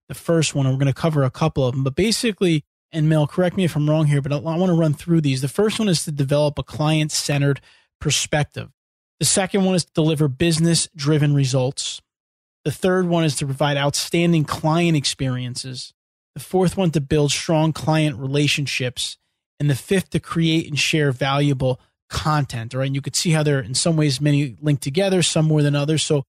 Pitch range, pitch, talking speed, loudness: 140-165 Hz, 150 Hz, 210 wpm, -20 LUFS